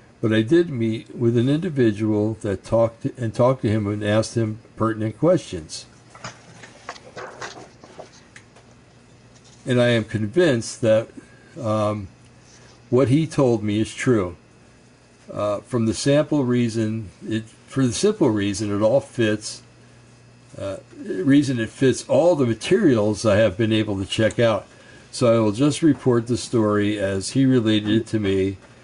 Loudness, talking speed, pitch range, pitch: -21 LUFS, 150 wpm, 110-125 Hz, 115 Hz